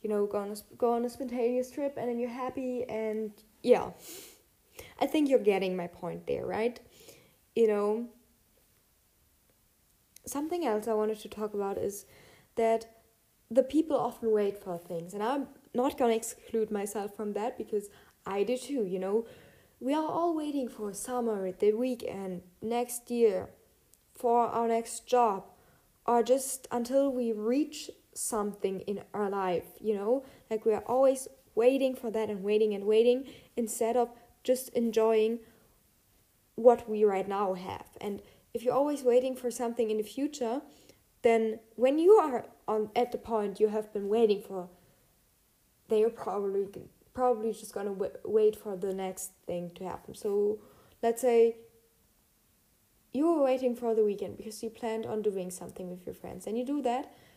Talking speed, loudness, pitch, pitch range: 170 wpm, -31 LUFS, 230 Hz, 210-250 Hz